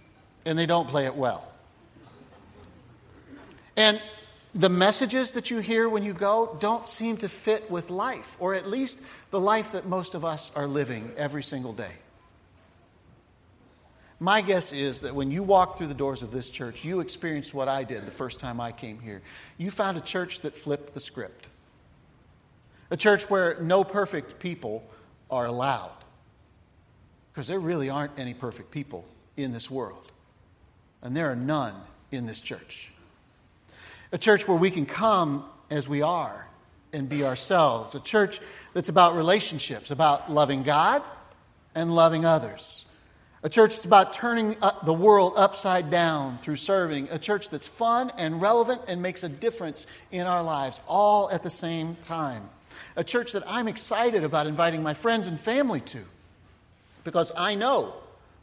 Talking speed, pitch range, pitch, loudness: 165 wpm, 125-195 Hz, 160 Hz, -26 LUFS